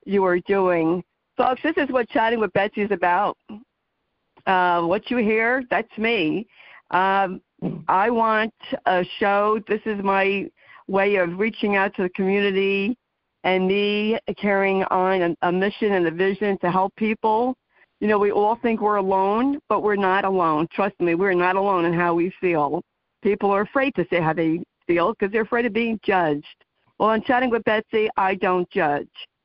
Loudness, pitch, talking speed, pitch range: -21 LUFS, 200 Hz, 180 wpm, 185-220 Hz